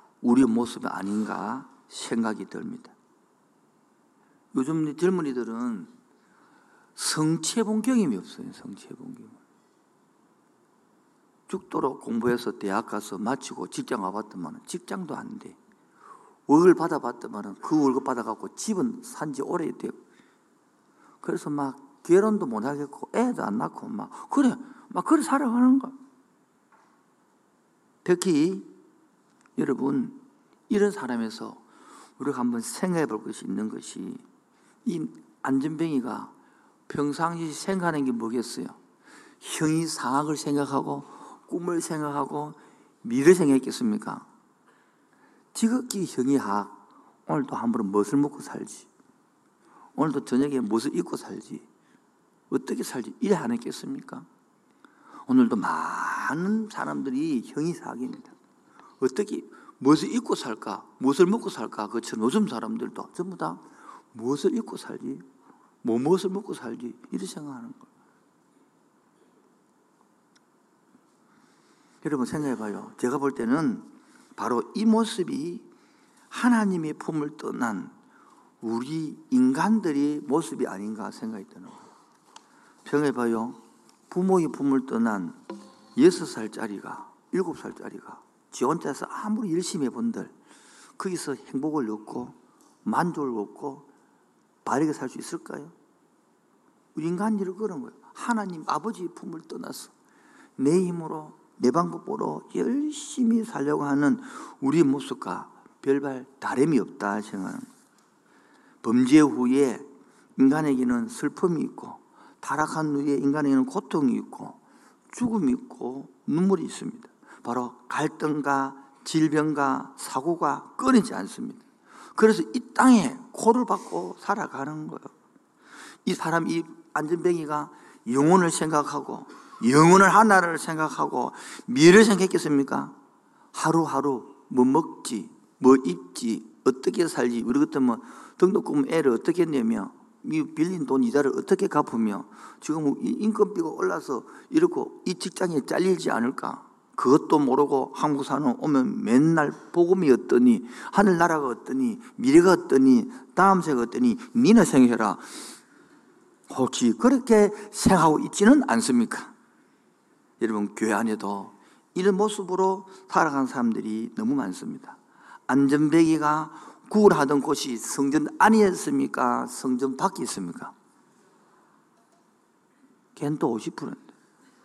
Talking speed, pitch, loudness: 255 characters per minute, 190 Hz, -25 LUFS